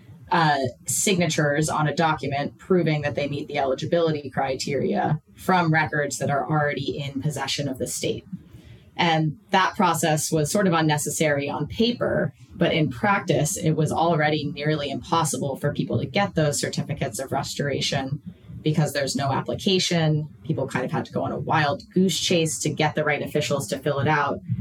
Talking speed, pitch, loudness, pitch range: 175 wpm, 150 Hz, -23 LUFS, 145-165 Hz